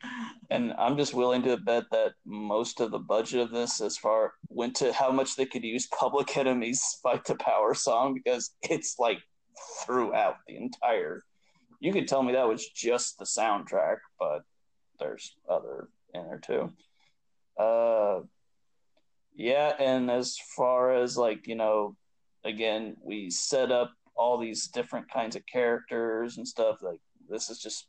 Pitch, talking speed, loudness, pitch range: 125 Hz, 160 wpm, -29 LUFS, 115-135 Hz